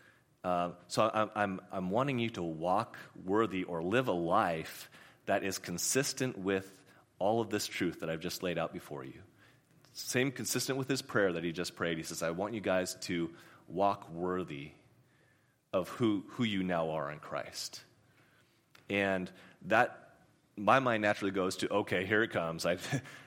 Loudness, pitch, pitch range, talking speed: -34 LUFS, 95 Hz, 85-115 Hz, 175 wpm